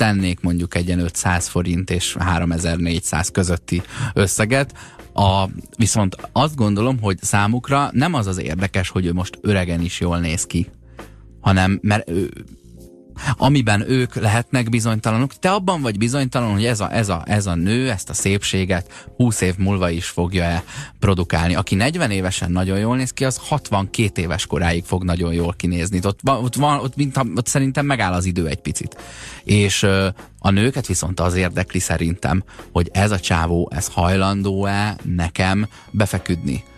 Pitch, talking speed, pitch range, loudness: 95 Hz, 160 wpm, 90-115 Hz, -19 LUFS